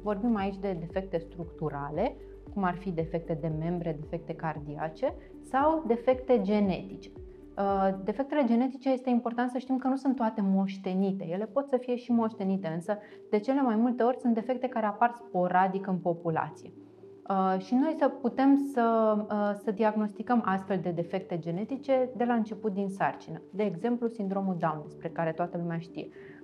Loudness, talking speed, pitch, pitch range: -30 LUFS, 160 wpm, 210 Hz, 180-245 Hz